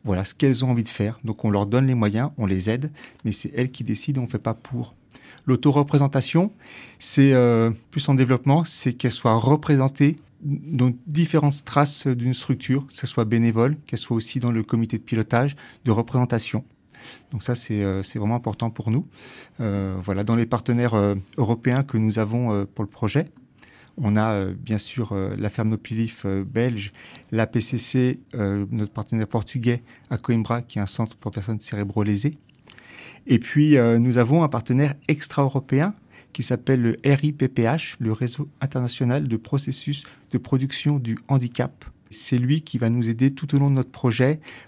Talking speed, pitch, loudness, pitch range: 185 wpm, 125 Hz, -23 LUFS, 110-135 Hz